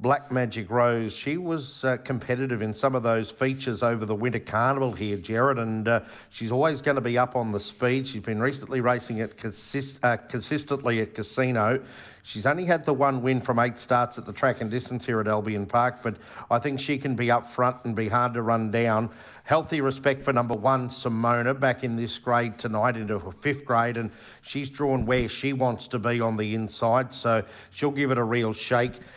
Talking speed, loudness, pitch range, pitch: 215 wpm, -26 LUFS, 115-130 Hz, 120 Hz